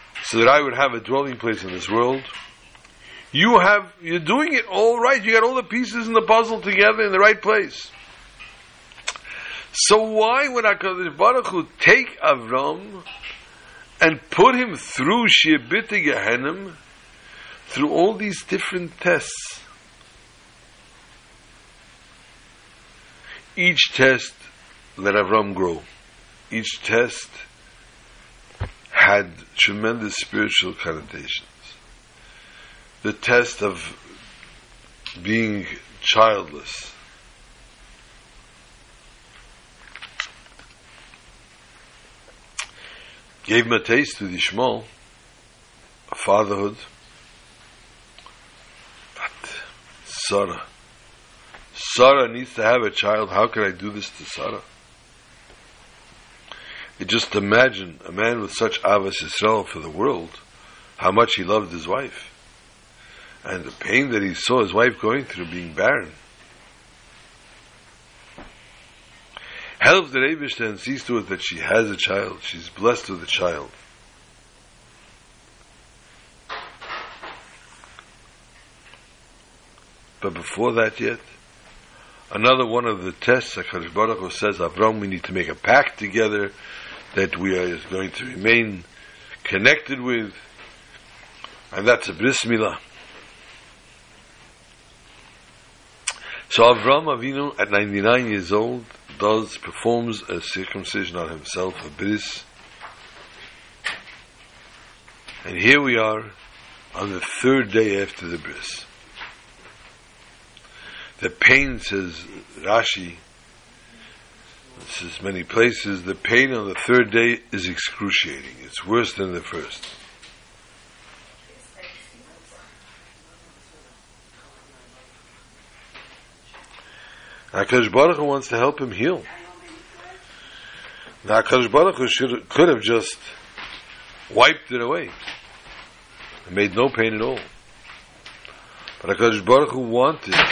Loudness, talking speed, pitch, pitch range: -20 LUFS, 100 wpm, 115 Hz, 100-140 Hz